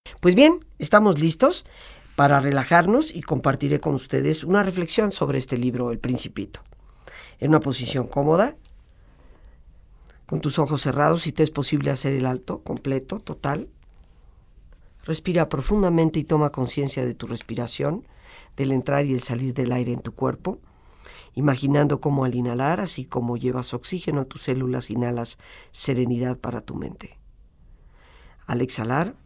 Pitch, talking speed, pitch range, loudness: 135 Hz, 145 wpm, 120-155 Hz, -23 LUFS